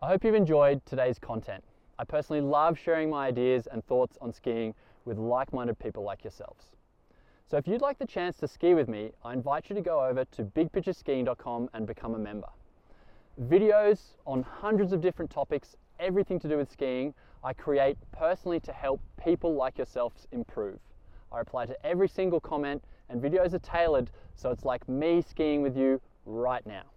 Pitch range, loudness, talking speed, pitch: 125-170 Hz, -30 LUFS, 185 wpm, 140 Hz